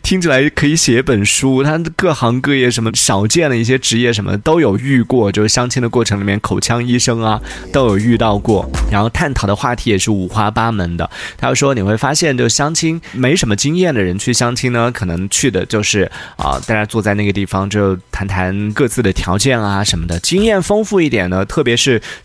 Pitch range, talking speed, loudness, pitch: 100-135 Hz, 325 characters per minute, -14 LUFS, 115 Hz